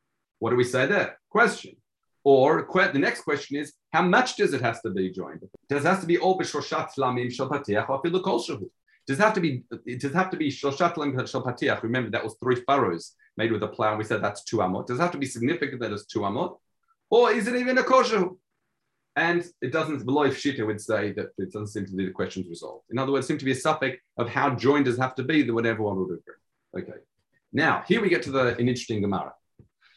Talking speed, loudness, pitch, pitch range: 215 wpm, -25 LUFS, 135 Hz, 120-160 Hz